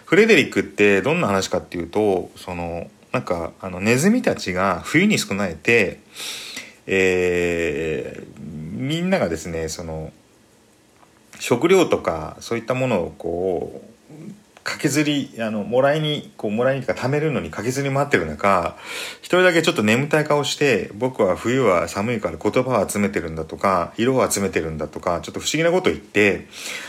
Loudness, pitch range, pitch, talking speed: -20 LUFS, 85-145 Hz, 105 Hz, 335 characters per minute